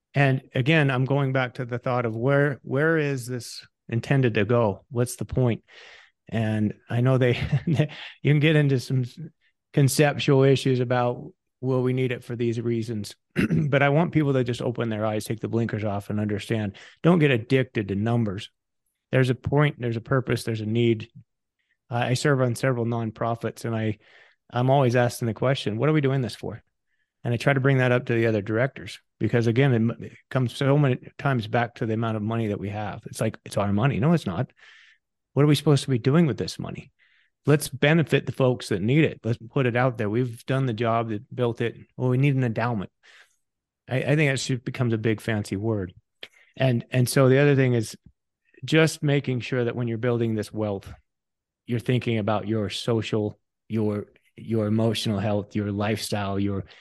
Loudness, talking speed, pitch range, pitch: -24 LUFS, 205 wpm, 110-135 Hz, 120 Hz